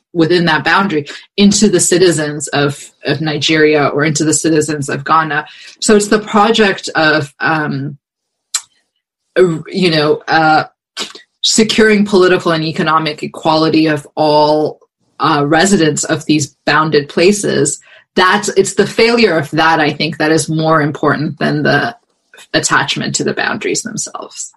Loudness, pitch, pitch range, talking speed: -12 LUFS, 160 Hz, 150-185 Hz, 135 wpm